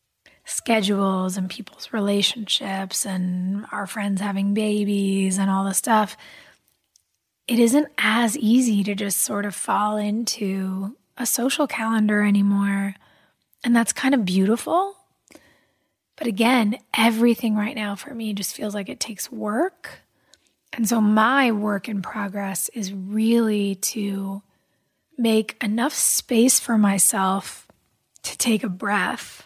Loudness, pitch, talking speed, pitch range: -22 LUFS, 210 Hz, 130 wpm, 200-230 Hz